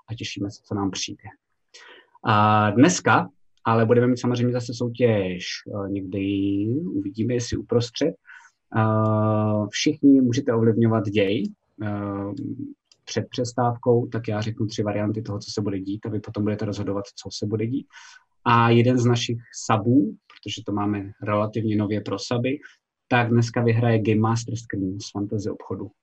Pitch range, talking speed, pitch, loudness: 105-120 Hz, 150 wpm, 110 Hz, -23 LUFS